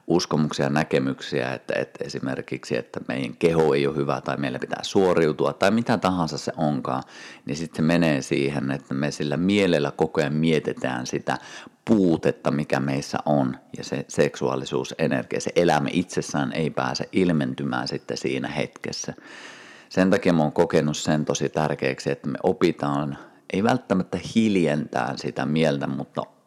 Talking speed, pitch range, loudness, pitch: 150 wpm, 70-80 Hz, -24 LUFS, 75 Hz